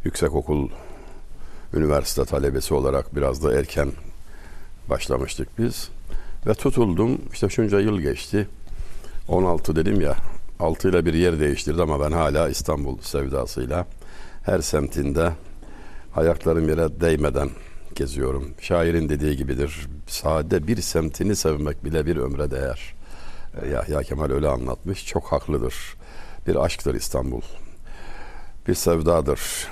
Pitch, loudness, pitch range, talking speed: 80 Hz, -23 LUFS, 70-85 Hz, 115 wpm